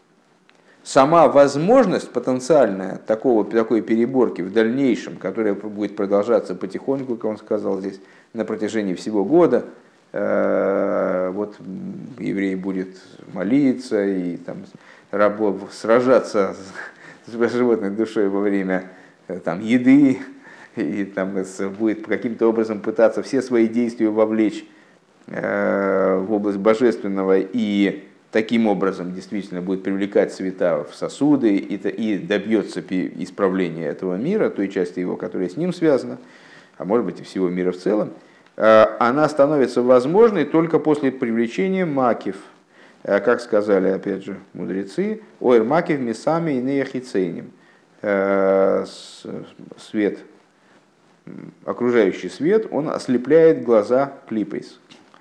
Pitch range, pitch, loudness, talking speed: 95-130 Hz, 110 Hz, -20 LUFS, 110 wpm